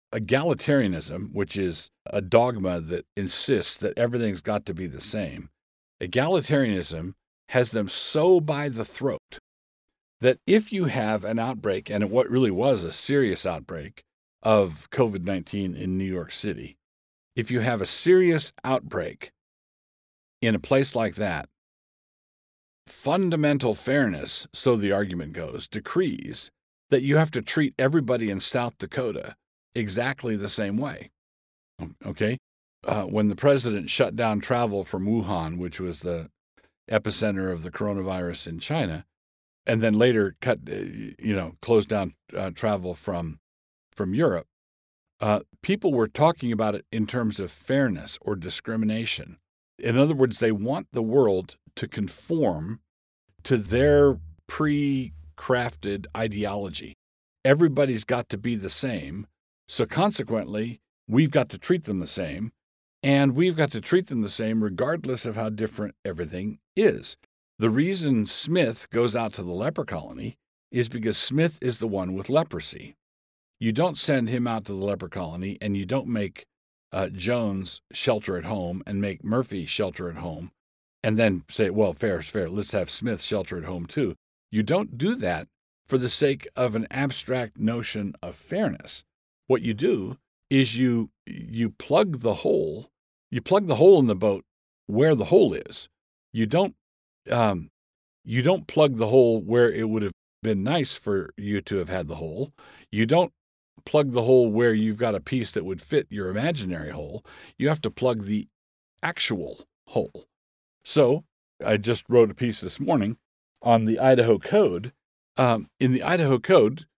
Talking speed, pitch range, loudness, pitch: 155 wpm, 95-125 Hz, -25 LUFS, 110 Hz